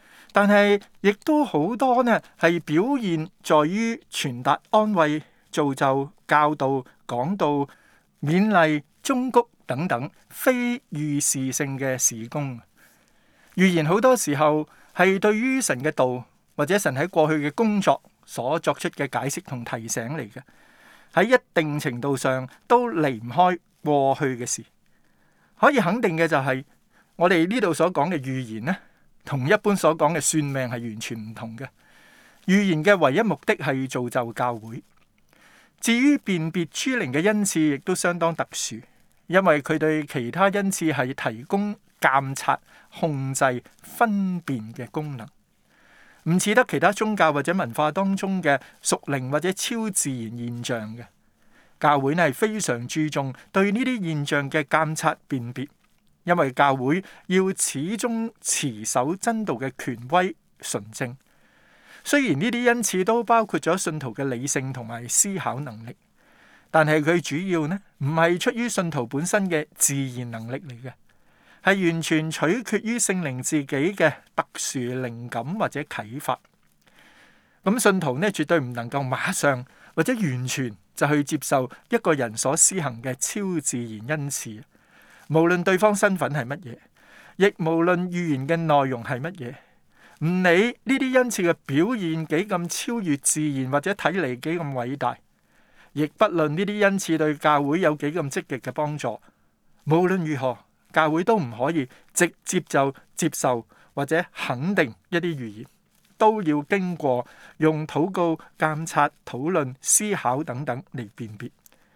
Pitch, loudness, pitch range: 155 Hz, -23 LUFS, 130-190 Hz